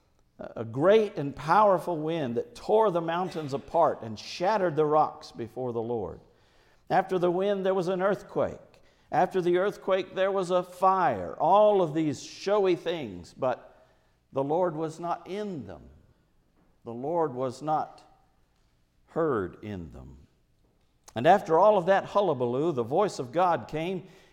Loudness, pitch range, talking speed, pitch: -27 LUFS, 120-190 Hz, 150 wpm, 165 Hz